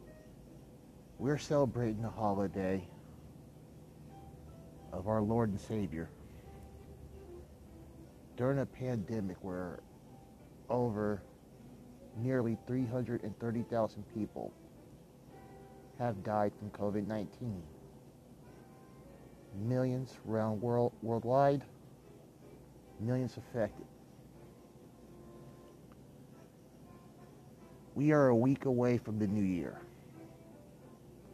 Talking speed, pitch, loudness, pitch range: 70 wpm, 110 Hz, -35 LUFS, 100-125 Hz